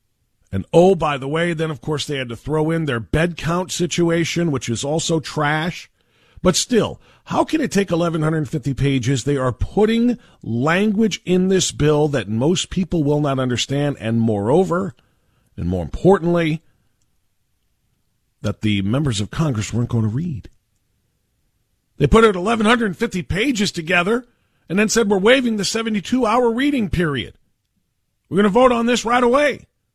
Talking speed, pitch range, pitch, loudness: 160 wpm, 120-195 Hz, 155 Hz, -19 LUFS